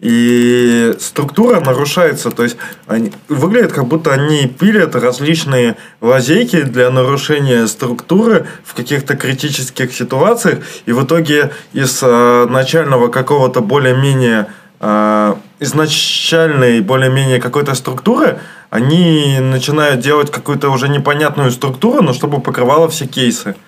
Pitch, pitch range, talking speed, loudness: 135 Hz, 125-150 Hz, 110 wpm, -12 LUFS